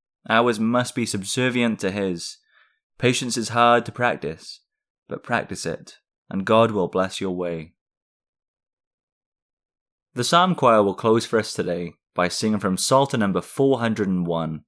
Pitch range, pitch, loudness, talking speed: 95-120 Hz, 110 Hz, -22 LUFS, 150 wpm